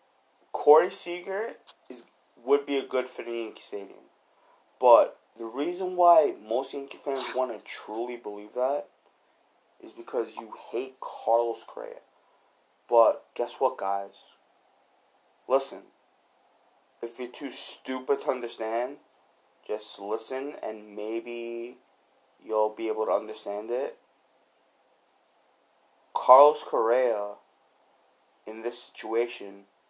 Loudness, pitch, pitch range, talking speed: -27 LUFS, 120 Hz, 105-140 Hz, 110 wpm